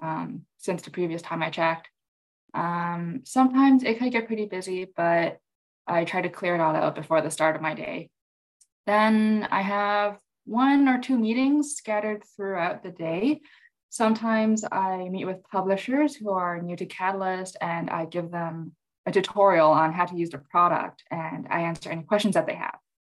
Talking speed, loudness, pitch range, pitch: 180 wpm, -25 LUFS, 170-220 Hz, 185 Hz